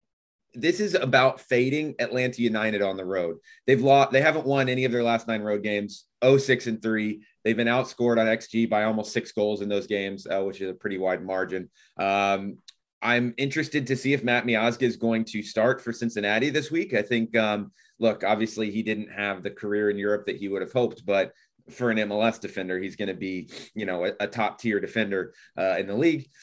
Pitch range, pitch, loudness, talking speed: 105-125 Hz, 110 Hz, -25 LUFS, 220 wpm